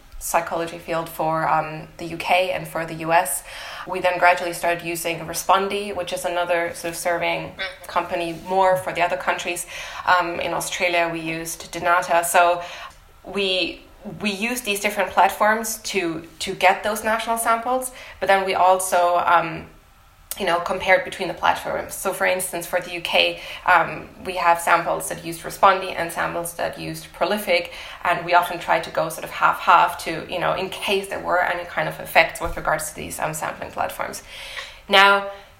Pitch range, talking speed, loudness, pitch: 170-190 Hz, 175 wpm, -21 LUFS, 175 Hz